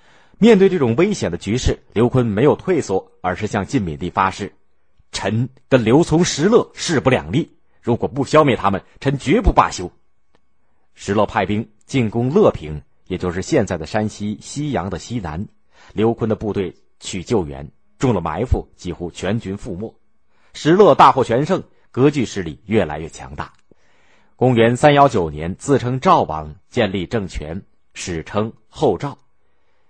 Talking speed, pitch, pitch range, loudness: 235 characters per minute, 105 Hz, 90-120 Hz, -18 LUFS